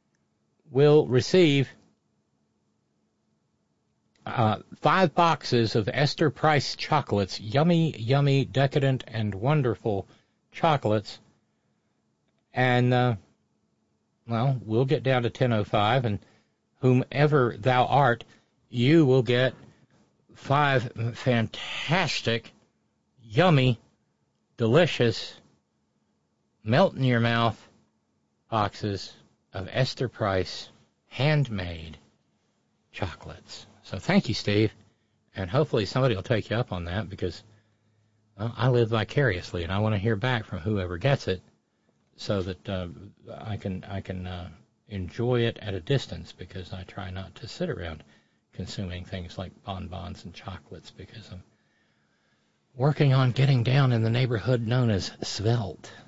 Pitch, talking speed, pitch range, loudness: 115 Hz, 115 wpm, 95-130 Hz, -25 LUFS